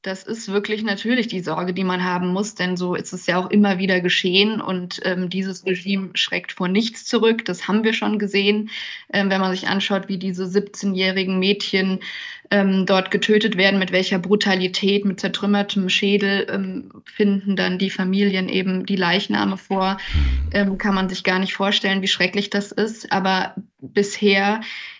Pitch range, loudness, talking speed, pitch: 185-205 Hz, -20 LUFS, 175 wpm, 195 Hz